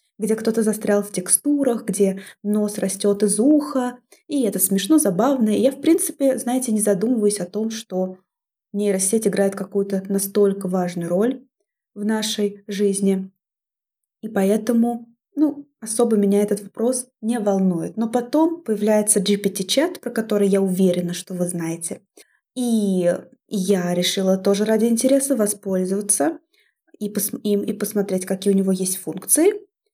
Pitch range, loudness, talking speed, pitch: 195-240 Hz, -20 LUFS, 135 wpm, 210 Hz